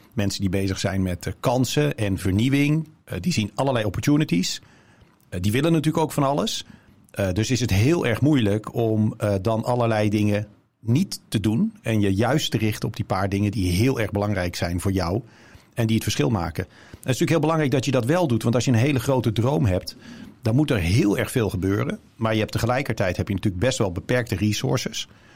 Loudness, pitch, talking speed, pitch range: -23 LUFS, 110 Hz, 210 wpm, 100-130 Hz